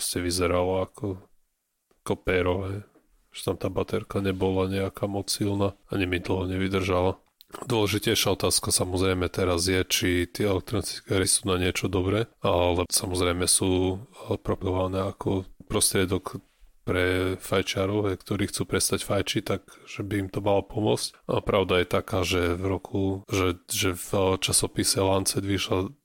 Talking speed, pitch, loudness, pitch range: 140 wpm, 95 Hz, -26 LUFS, 90-100 Hz